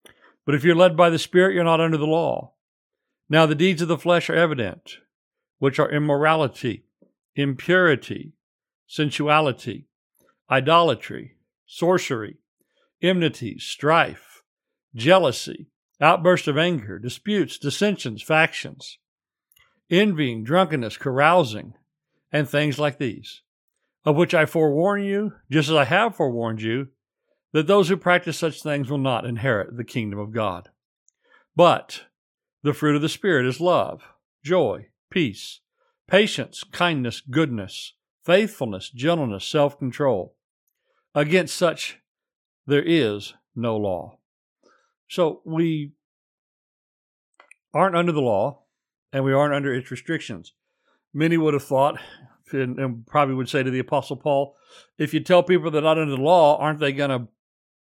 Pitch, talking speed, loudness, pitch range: 150 Hz, 130 wpm, -21 LUFS, 130-170 Hz